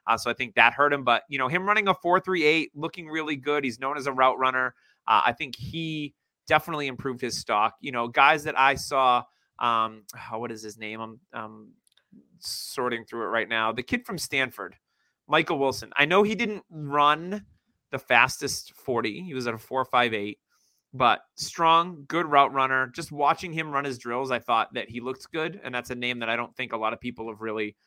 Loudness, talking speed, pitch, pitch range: -25 LUFS, 215 wpm, 130 Hz, 120-155 Hz